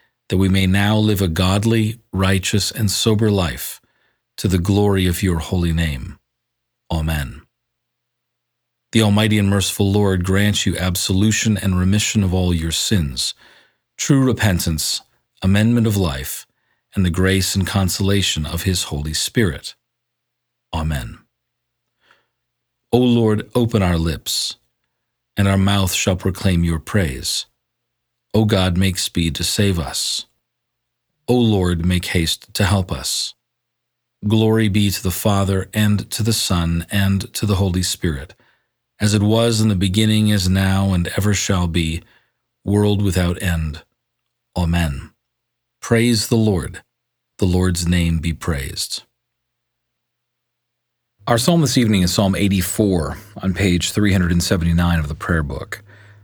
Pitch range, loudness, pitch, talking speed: 90-110 Hz, -18 LUFS, 95 Hz, 135 wpm